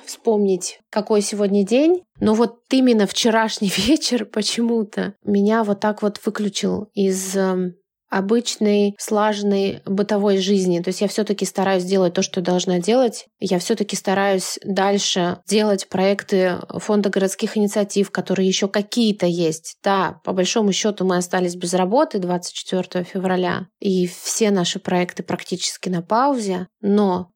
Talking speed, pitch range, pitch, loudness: 135 wpm, 185-215 Hz, 200 Hz, -20 LUFS